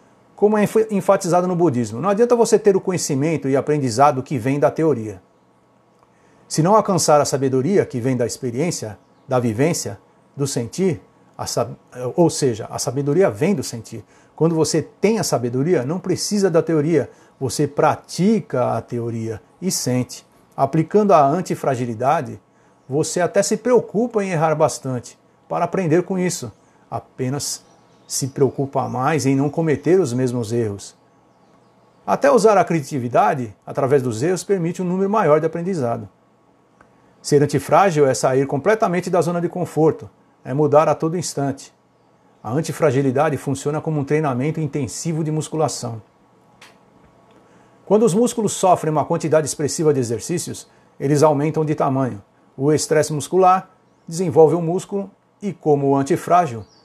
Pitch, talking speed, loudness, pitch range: 150 Hz, 145 wpm, -19 LUFS, 135-175 Hz